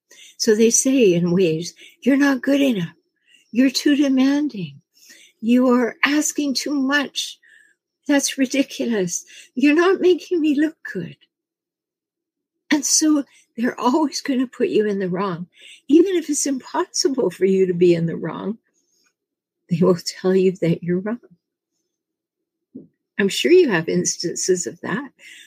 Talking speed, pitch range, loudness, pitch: 145 wpm, 210-335 Hz, -19 LUFS, 280 Hz